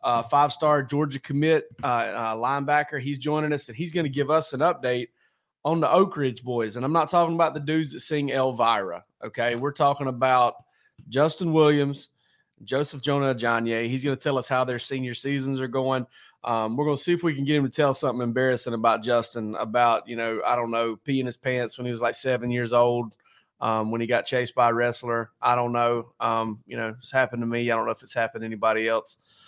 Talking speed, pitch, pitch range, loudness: 230 wpm, 125 Hz, 120-145 Hz, -25 LUFS